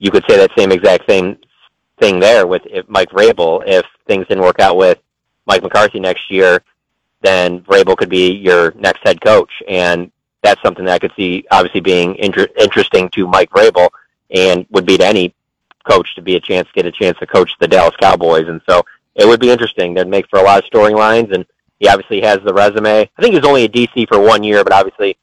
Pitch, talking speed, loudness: 110 Hz, 225 wpm, -11 LUFS